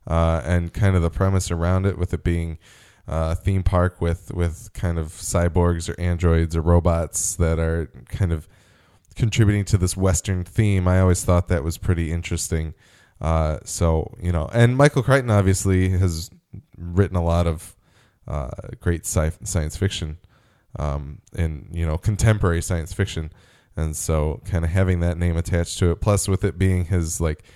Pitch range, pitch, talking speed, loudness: 85-100 Hz, 90 Hz, 175 wpm, -22 LUFS